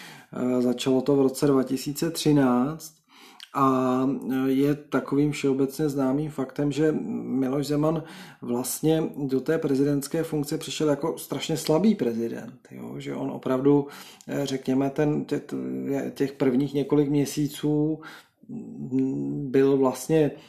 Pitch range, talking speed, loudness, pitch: 130-150 Hz, 110 wpm, -25 LUFS, 140 Hz